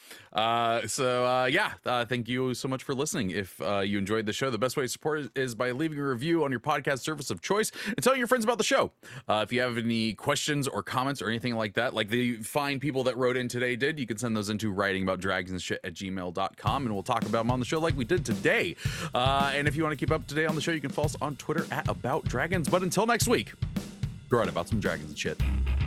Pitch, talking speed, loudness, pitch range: 125 Hz, 275 wpm, -29 LUFS, 110-150 Hz